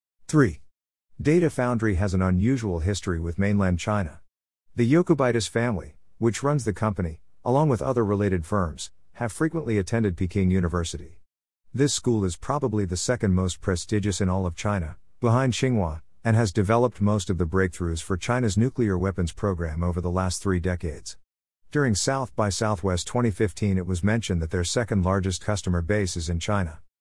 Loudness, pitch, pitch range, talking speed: -25 LUFS, 100 Hz, 90-115 Hz, 165 wpm